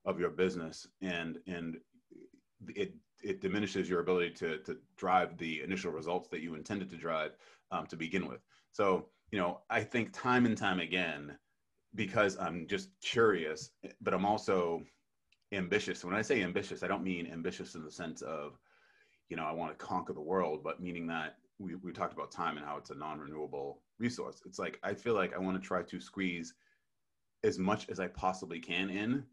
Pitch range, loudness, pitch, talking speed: 85-105 Hz, -36 LUFS, 90 Hz, 190 wpm